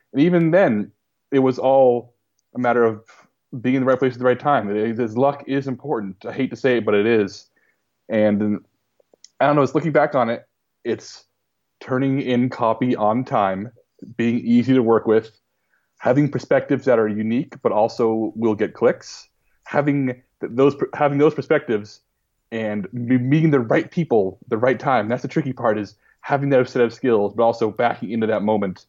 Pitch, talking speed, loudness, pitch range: 125 Hz, 190 wpm, -20 LUFS, 110-135 Hz